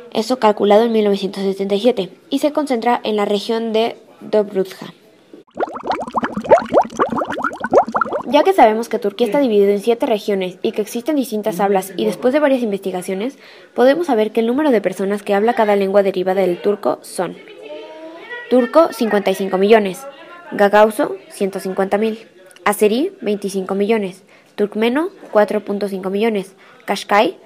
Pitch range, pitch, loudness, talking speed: 195-240 Hz, 210 Hz, -17 LUFS, 130 wpm